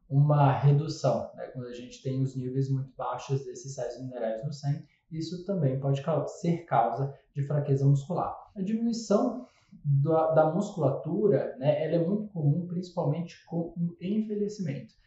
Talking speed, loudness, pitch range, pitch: 155 wpm, -29 LUFS, 135-175 Hz, 155 Hz